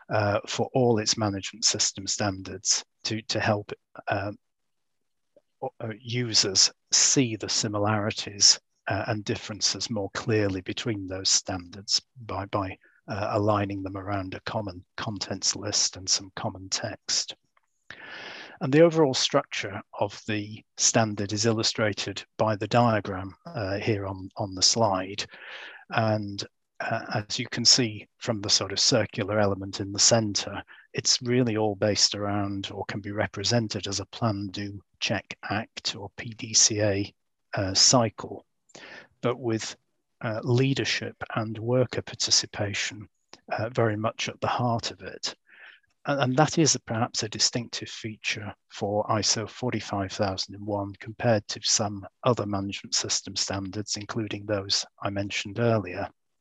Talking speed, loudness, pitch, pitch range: 135 wpm, -26 LUFS, 105 Hz, 100-115 Hz